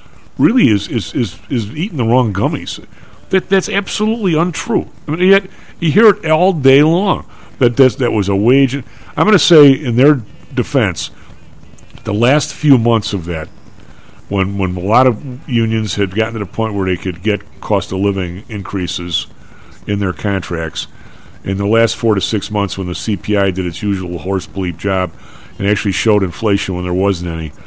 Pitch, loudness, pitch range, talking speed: 105 Hz, -15 LUFS, 95-135 Hz, 190 wpm